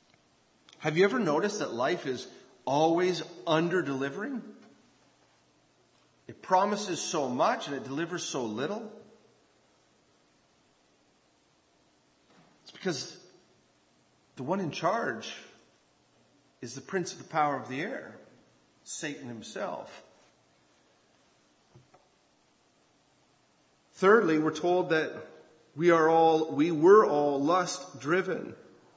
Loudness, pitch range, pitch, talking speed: -28 LUFS, 145-185 Hz, 165 Hz, 100 wpm